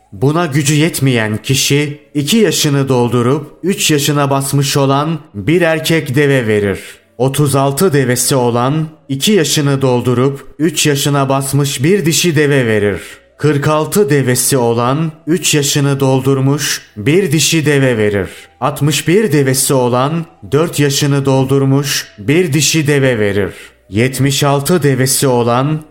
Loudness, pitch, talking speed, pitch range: -12 LUFS, 140 Hz, 120 wpm, 130-155 Hz